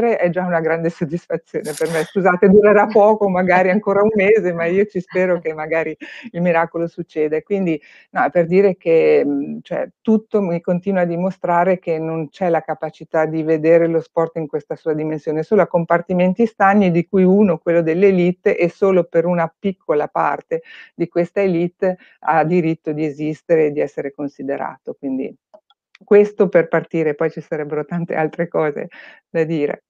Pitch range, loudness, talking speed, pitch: 160-195 Hz, -17 LUFS, 170 wpm, 175 Hz